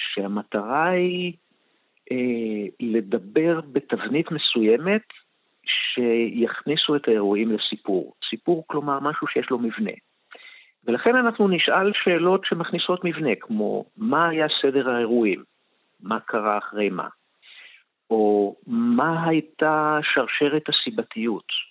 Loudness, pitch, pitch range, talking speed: -23 LUFS, 155 Hz, 115-180 Hz, 100 wpm